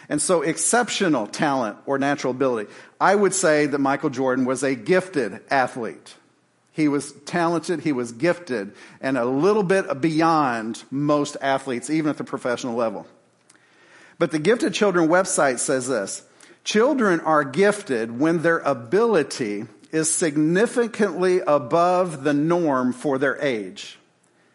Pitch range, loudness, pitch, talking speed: 140-180 Hz, -21 LUFS, 155 Hz, 135 wpm